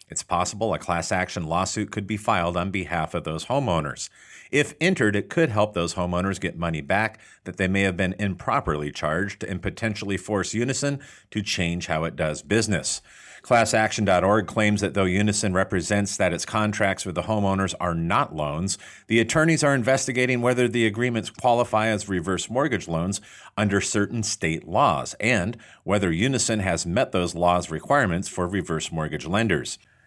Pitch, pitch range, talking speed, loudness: 100 Hz, 90-110 Hz, 170 wpm, -24 LUFS